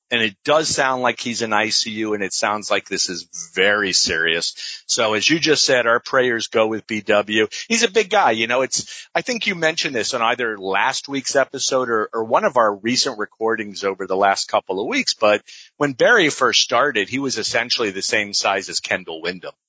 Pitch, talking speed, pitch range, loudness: 115 Hz, 215 wpm, 105-135 Hz, -19 LUFS